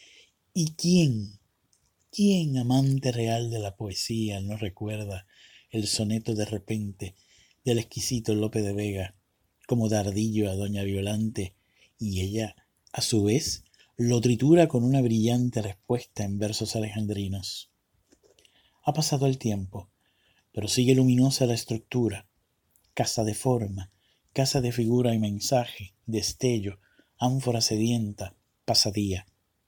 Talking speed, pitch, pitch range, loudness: 120 wpm, 110 Hz, 100-120 Hz, -27 LUFS